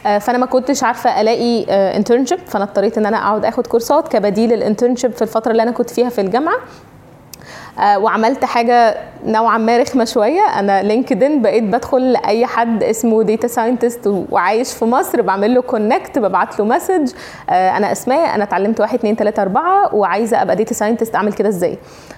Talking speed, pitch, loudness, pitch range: 170 wpm, 230 Hz, -15 LUFS, 210-245 Hz